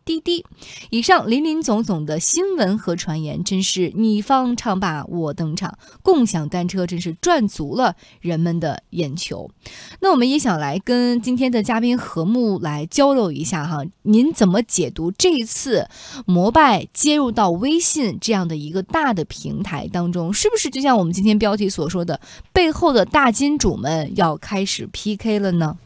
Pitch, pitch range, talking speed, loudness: 205 Hz, 175-250 Hz, 260 characters per minute, -19 LUFS